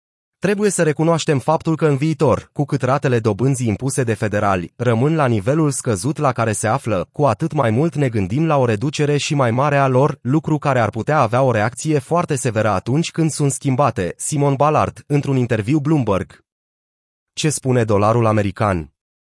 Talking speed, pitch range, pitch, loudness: 180 wpm, 115-150 Hz, 135 Hz, -18 LUFS